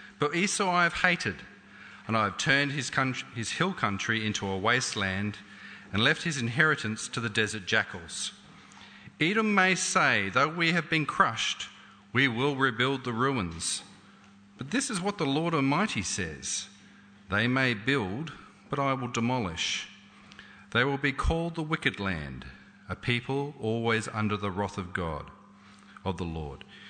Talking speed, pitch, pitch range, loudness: 160 wpm, 120 Hz, 100-145 Hz, -28 LUFS